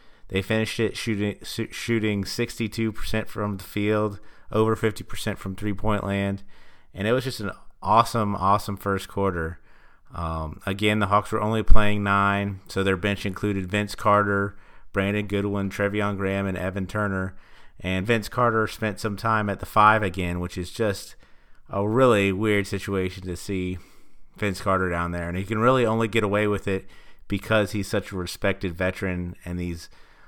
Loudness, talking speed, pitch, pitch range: -25 LUFS, 175 wpm, 100 Hz, 95-105 Hz